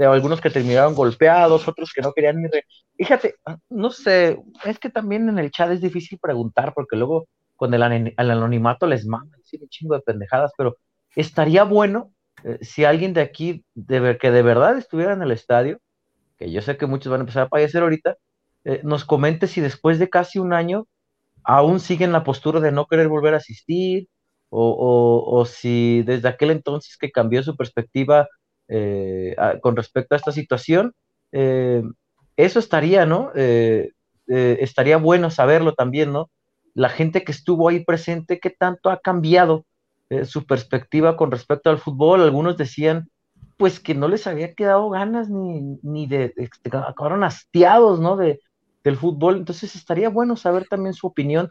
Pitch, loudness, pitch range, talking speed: 155 Hz, -19 LUFS, 130-175 Hz, 175 wpm